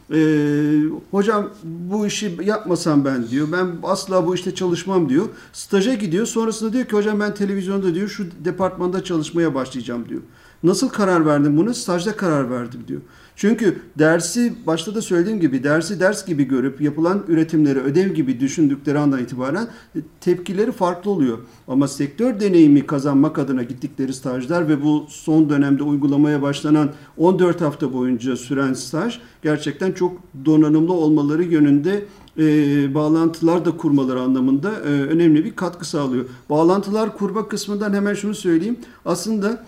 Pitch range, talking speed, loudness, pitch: 145-195 Hz, 145 wpm, -19 LUFS, 165 Hz